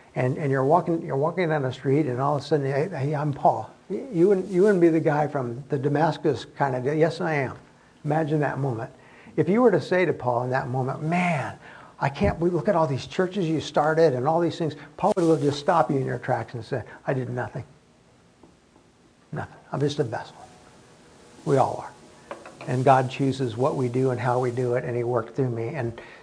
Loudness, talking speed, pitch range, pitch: -24 LUFS, 230 wpm, 130-160 Hz, 145 Hz